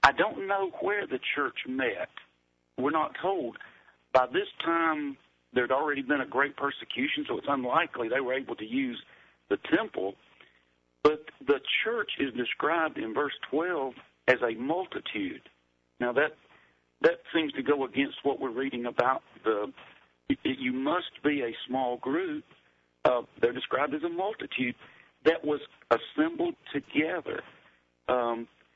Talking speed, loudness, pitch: 145 wpm, -30 LUFS, 145 Hz